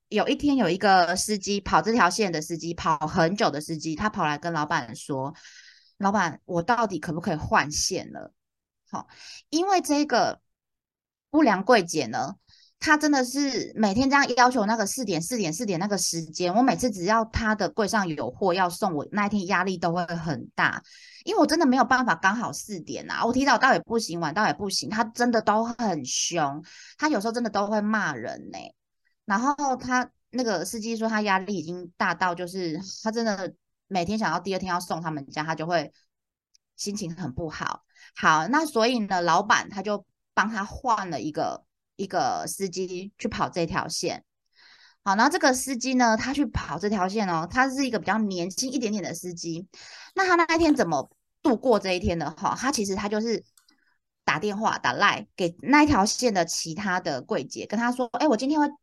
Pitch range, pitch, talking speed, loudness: 180-250 Hz, 215 Hz, 285 characters per minute, -25 LUFS